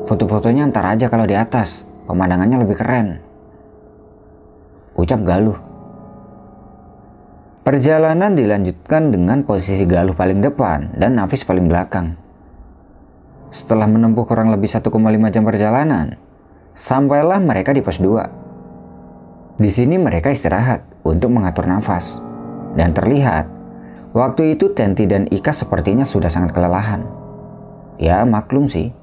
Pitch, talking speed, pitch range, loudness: 110 Hz, 115 wpm, 95-130 Hz, -16 LUFS